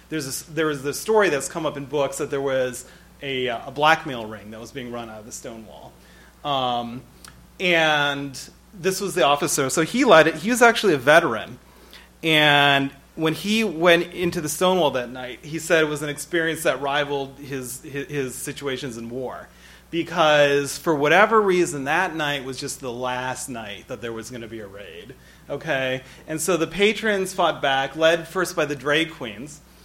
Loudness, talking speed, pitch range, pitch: -21 LUFS, 185 wpm, 130-165 Hz, 145 Hz